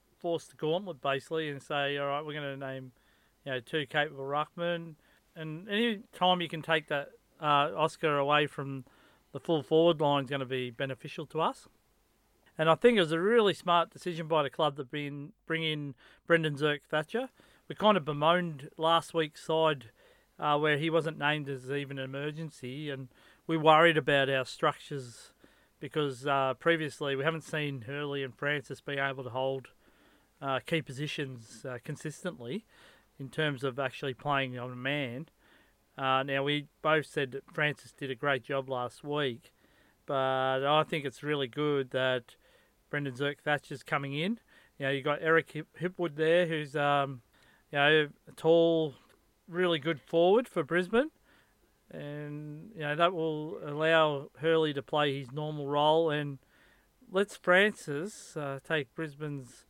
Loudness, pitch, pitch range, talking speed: -31 LUFS, 150 Hz, 140-160 Hz, 170 wpm